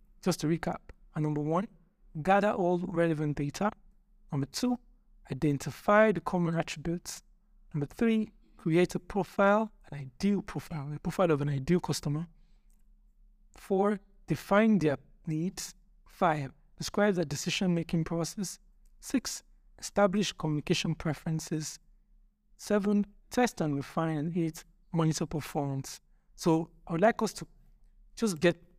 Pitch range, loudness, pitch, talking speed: 160-205 Hz, -31 LUFS, 180 Hz, 125 wpm